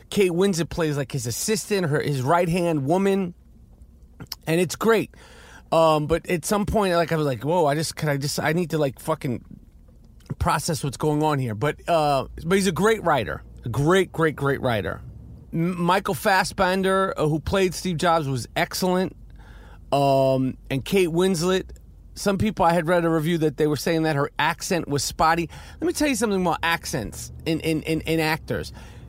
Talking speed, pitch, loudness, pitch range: 190 wpm, 165 Hz, -23 LUFS, 145-185 Hz